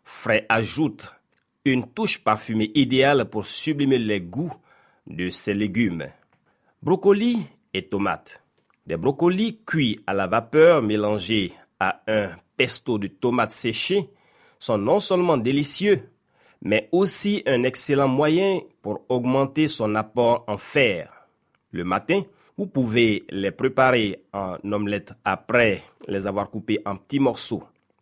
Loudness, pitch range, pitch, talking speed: -22 LUFS, 105-155 Hz, 125 Hz, 125 wpm